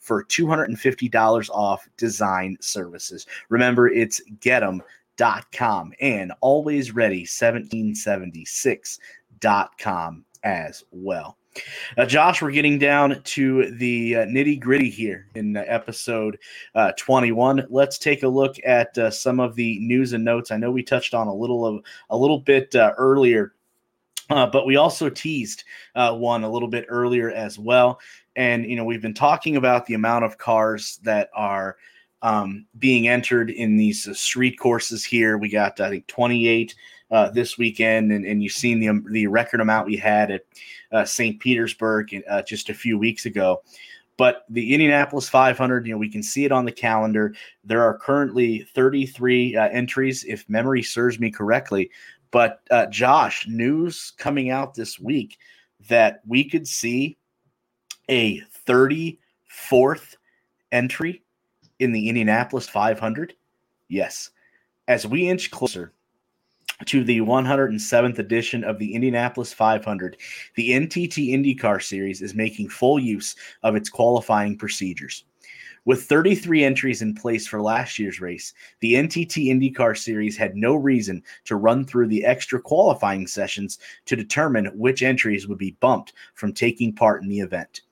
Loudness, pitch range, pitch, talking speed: -21 LUFS, 110-130 Hz, 120 Hz, 150 wpm